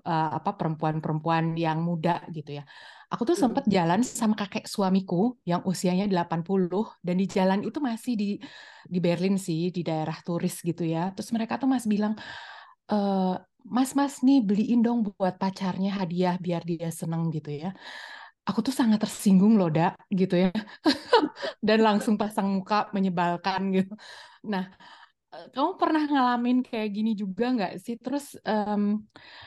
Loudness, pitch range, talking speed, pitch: -26 LUFS, 180-235 Hz, 155 wpm, 200 Hz